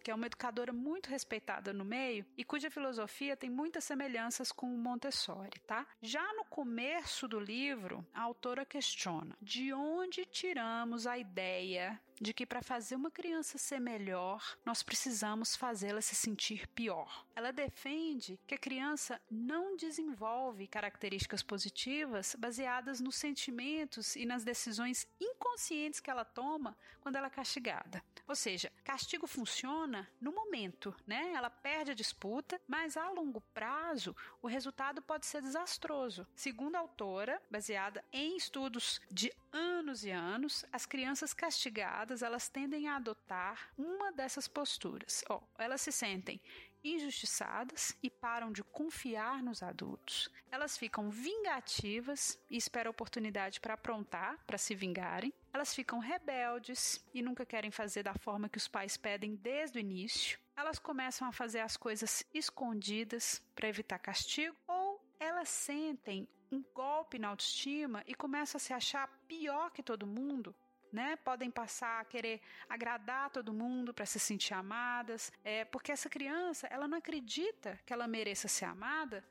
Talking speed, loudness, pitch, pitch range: 150 wpm, -40 LUFS, 250 Hz, 220-290 Hz